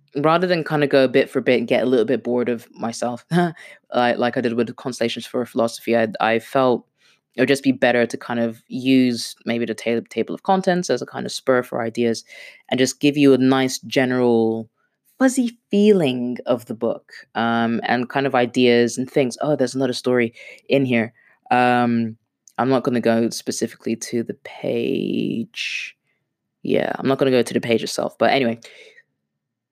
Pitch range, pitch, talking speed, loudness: 115-135 Hz, 125 Hz, 195 wpm, -20 LUFS